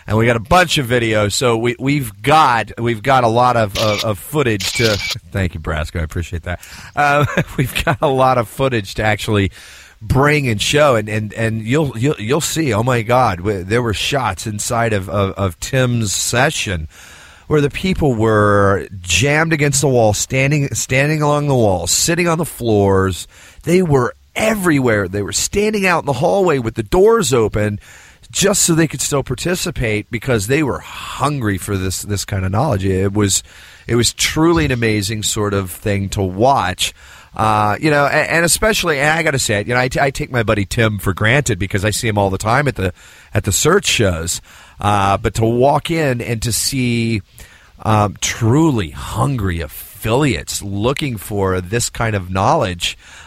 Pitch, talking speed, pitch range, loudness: 115 Hz, 195 wpm, 100-140 Hz, -16 LUFS